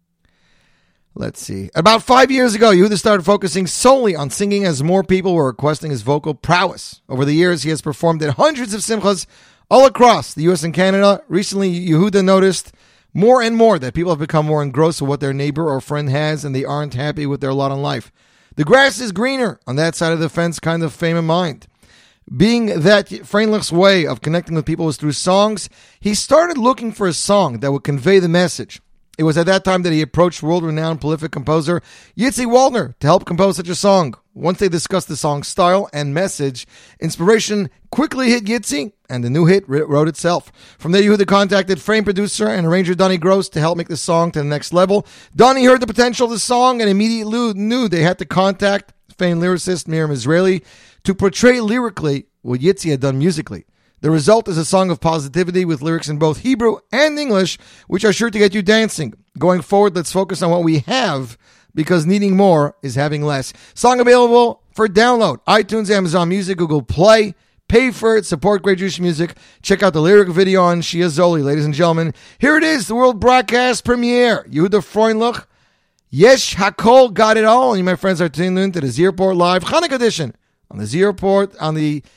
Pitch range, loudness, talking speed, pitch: 160-210 Hz, -15 LUFS, 205 wpm, 185 Hz